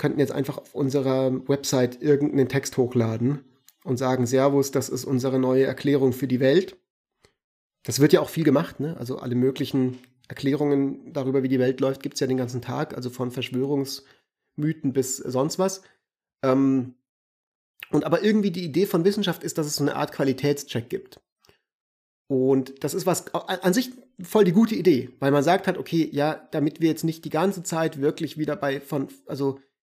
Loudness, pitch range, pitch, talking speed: -24 LUFS, 130-160 Hz, 140 Hz, 185 wpm